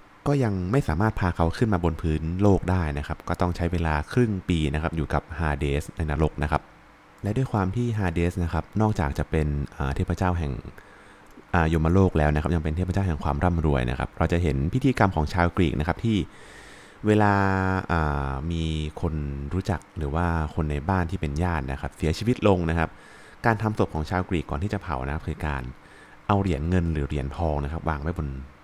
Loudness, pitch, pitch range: -26 LUFS, 85 Hz, 75-95 Hz